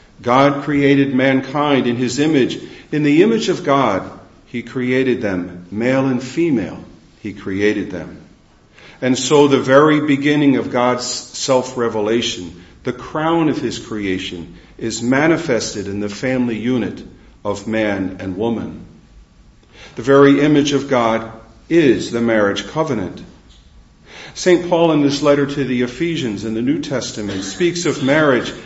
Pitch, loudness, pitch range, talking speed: 125 Hz, -16 LUFS, 105-140 Hz, 140 wpm